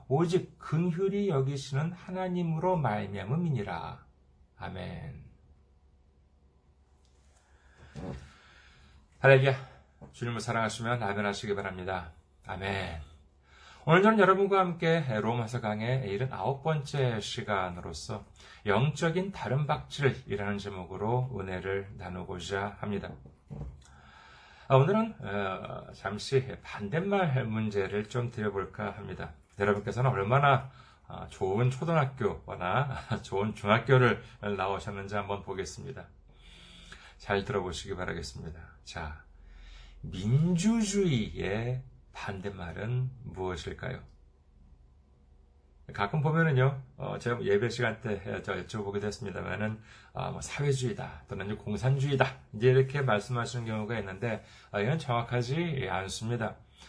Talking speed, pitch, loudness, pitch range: 240 characters per minute, 105 Hz, -31 LUFS, 90-130 Hz